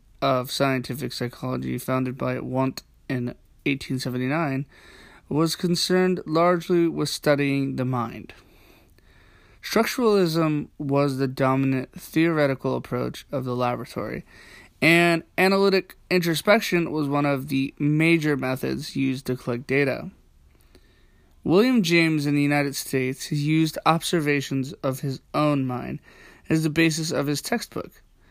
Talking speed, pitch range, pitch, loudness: 115 wpm, 130-165 Hz, 140 Hz, -23 LUFS